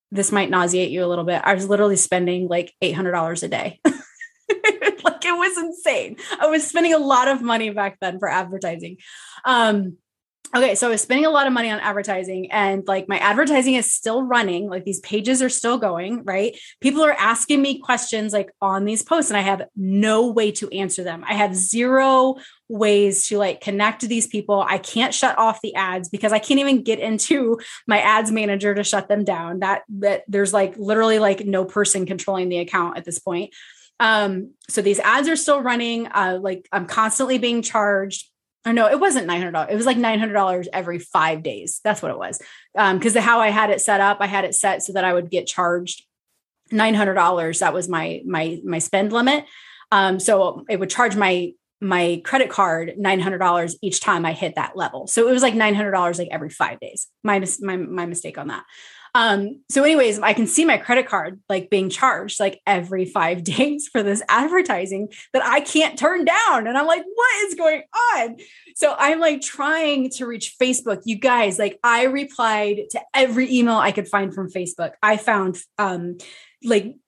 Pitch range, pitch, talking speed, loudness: 190-255 Hz, 210 Hz, 200 wpm, -19 LUFS